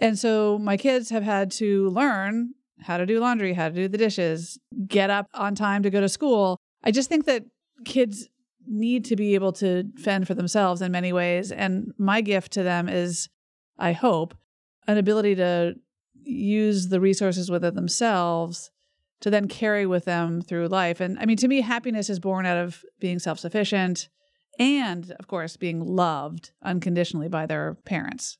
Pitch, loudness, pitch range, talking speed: 195 Hz, -24 LUFS, 175-220 Hz, 180 wpm